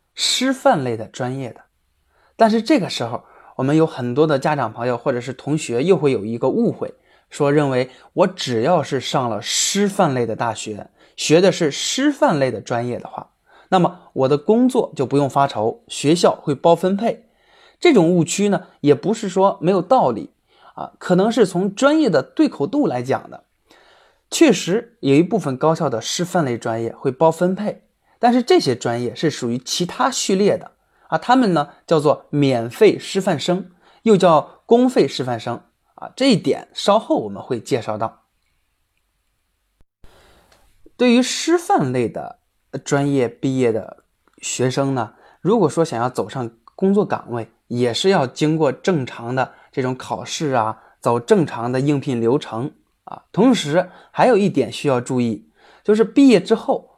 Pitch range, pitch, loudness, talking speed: 120-195 Hz, 145 Hz, -18 LUFS, 240 characters per minute